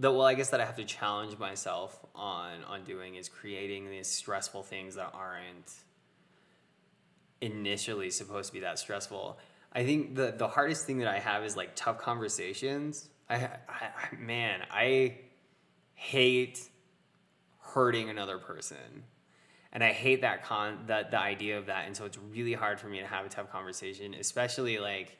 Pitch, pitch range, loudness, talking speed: 105 Hz, 100-125 Hz, -33 LUFS, 170 wpm